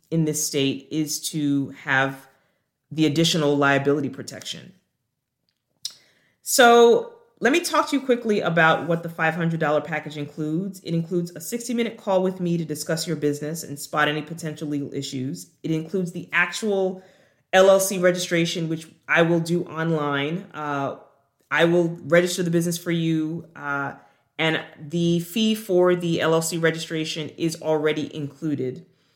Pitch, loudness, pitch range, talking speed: 160 Hz, -22 LUFS, 150-175 Hz, 145 wpm